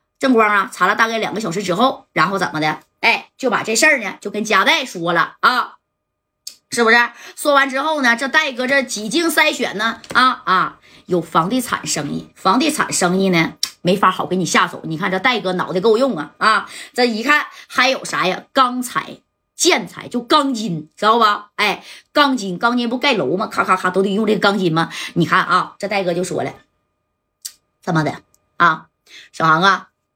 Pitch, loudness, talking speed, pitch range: 215 Hz, -17 LUFS, 265 characters per minute, 185-260 Hz